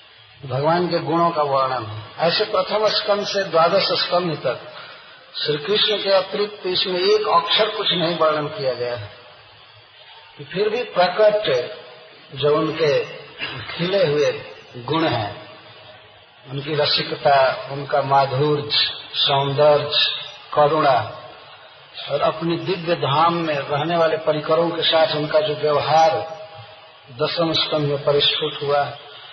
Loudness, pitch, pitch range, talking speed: -19 LUFS, 155 Hz, 145-180 Hz, 125 wpm